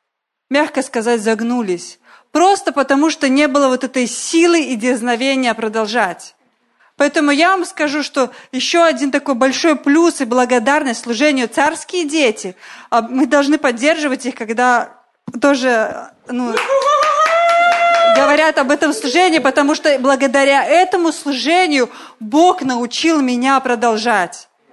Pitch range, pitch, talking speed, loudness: 250-315 Hz, 280 Hz, 120 wpm, -14 LUFS